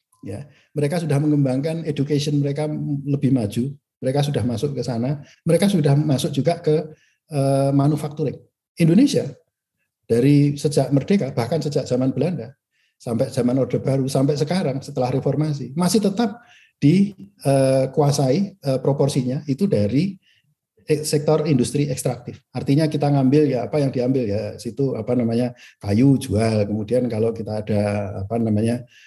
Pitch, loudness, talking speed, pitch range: 140 Hz, -21 LUFS, 130 wpm, 125-150 Hz